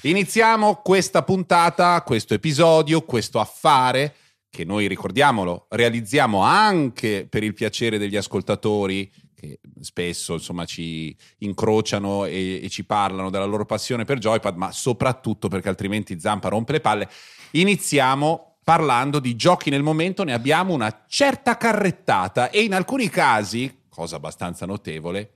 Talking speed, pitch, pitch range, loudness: 135 wpm, 115 Hz, 100-165 Hz, -21 LUFS